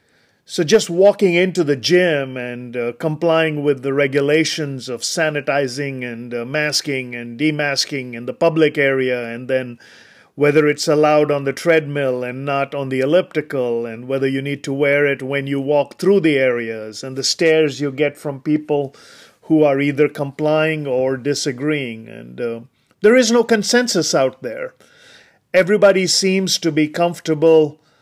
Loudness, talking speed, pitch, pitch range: -17 LUFS, 160 wpm, 145 Hz, 135-160 Hz